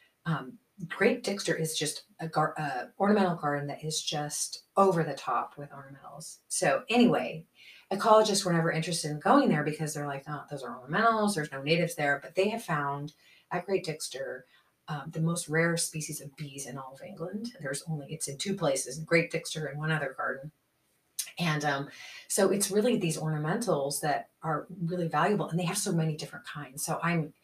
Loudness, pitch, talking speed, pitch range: -30 LUFS, 160 Hz, 190 wpm, 150-185 Hz